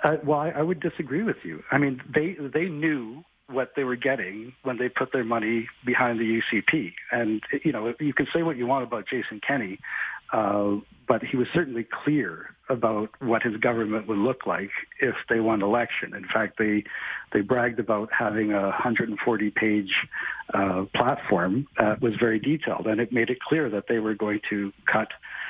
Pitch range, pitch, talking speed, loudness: 110-140 Hz, 120 Hz, 185 wpm, -26 LUFS